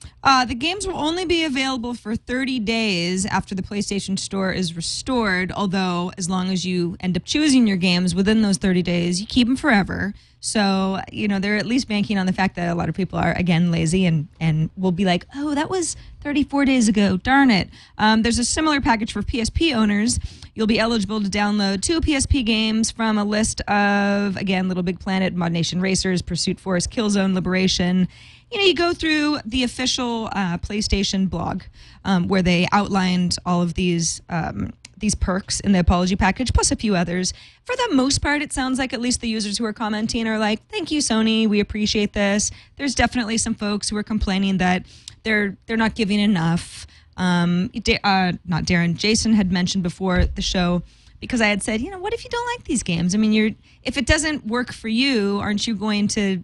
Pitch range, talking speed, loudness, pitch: 185-235 Hz, 210 wpm, -21 LUFS, 205 Hz